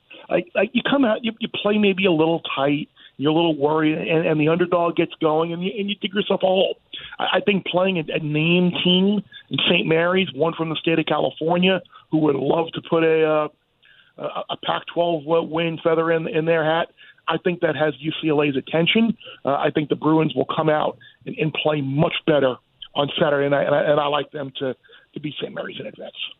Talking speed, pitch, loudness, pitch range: 220 wpm, 165 Hz, -21 LUFS, 155-180 Hz